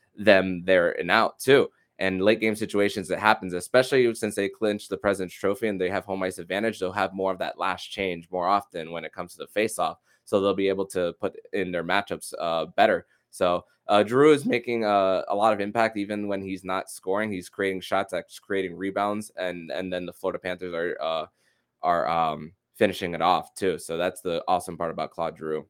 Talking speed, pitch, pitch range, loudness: 215 wpm, 100 Hz, 95-105 Hz, -26 LUFS